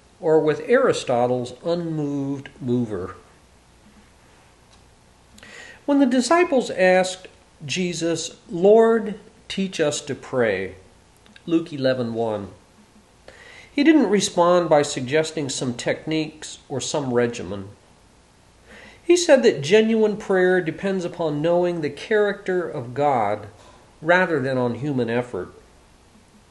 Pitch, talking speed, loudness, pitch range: 155 Hz, 100 wpm, -21 LUFS, 120-185 Hz